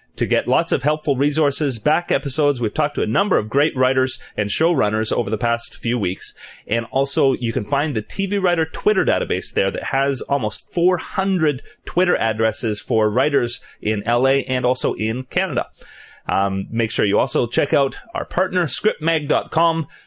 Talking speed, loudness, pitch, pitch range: 175 wpm, -20 LUFS, 135 Hz, 115-155 Hz